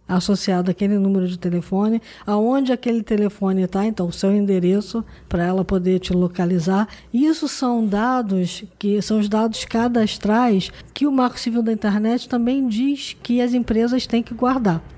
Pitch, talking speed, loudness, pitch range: 215 Hz, 160 wpm, -20 LUFS, 190-240 Hz